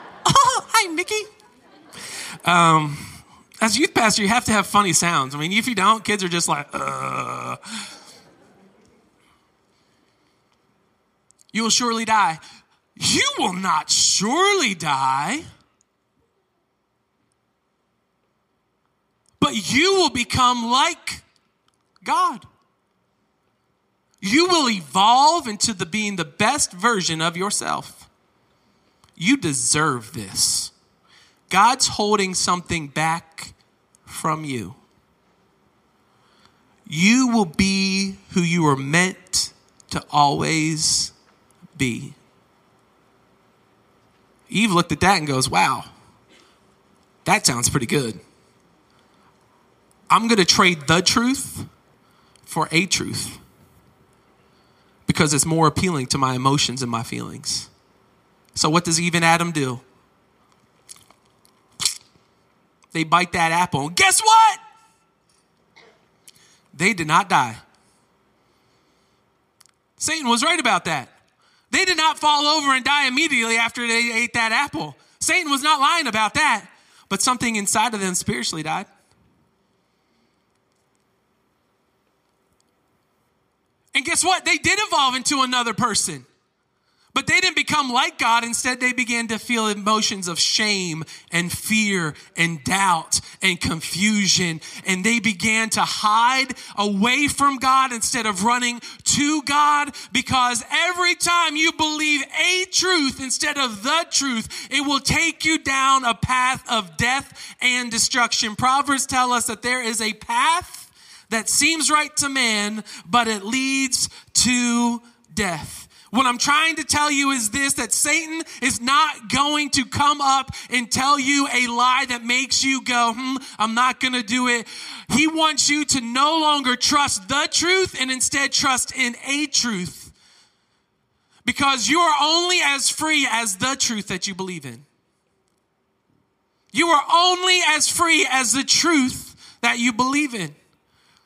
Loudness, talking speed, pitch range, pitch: -19 LUFS, 125 wpm, 190-285 Hz, 240 Hz